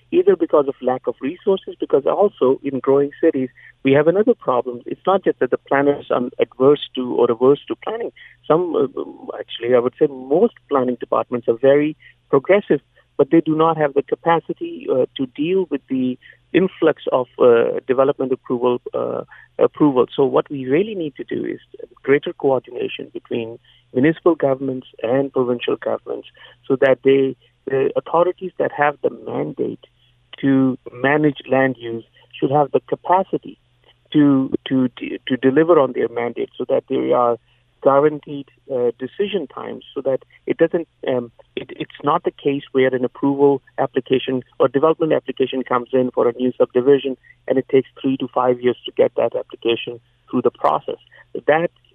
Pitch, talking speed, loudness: 140 Hz, 165 wpm, -19 LUFS